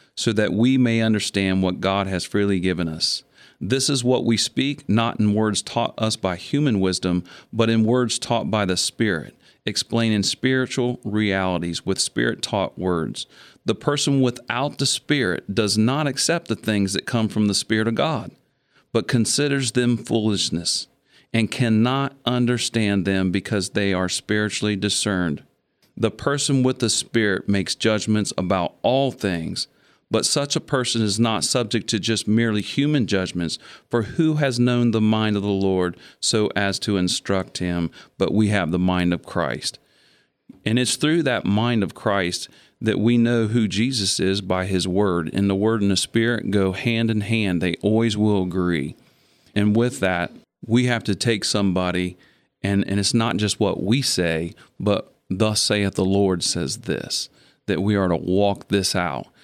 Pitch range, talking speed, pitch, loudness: 95-120 Hz, 175 wpm, 105 Hz, -21 LUFS